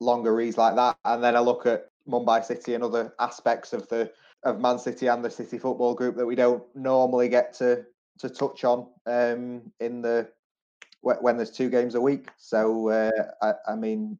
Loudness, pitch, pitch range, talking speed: -25 LUFS, 120 Hz, 115-125 Hz, 200 wpm